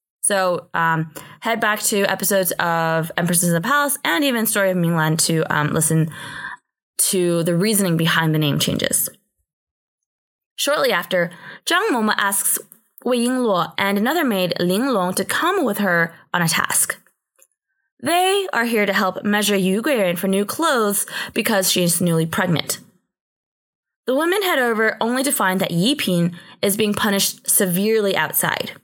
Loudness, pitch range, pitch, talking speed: -19 LUFS, 170-220 Hz, 195 Hz, 155 wpm